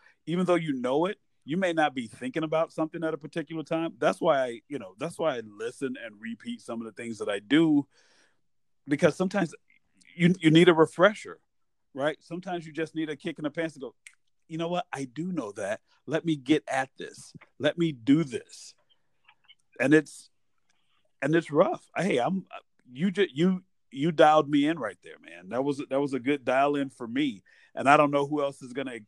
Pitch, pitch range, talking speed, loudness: 160 Hz, 140-175 Hz, 215 wpm, -27 LUFS